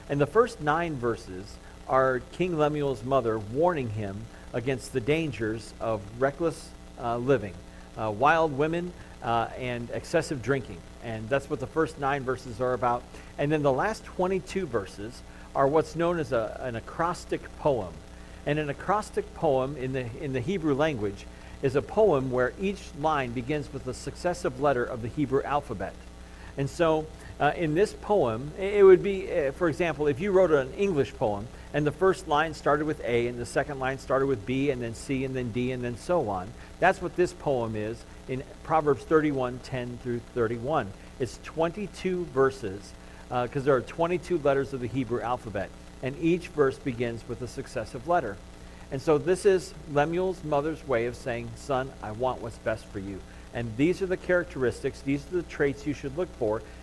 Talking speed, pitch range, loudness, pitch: 185 wpm, 120-160 Hz, -28 LUFS, 135 Hz